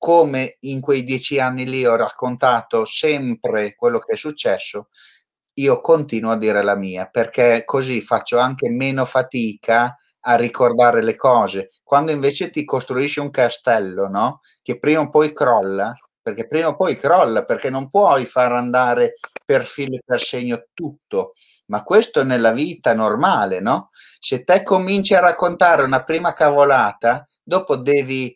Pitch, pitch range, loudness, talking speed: 130 Hz, 120-155 Hz, -18 LUFS, 155 wpm